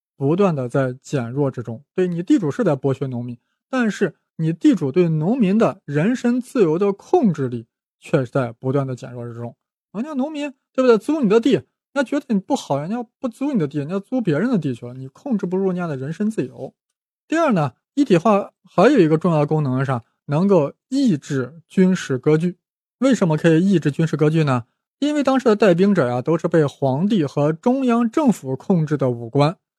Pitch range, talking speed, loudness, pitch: 140-225 Hz, 305 characters per minute, -19 LUFS, 175 Hz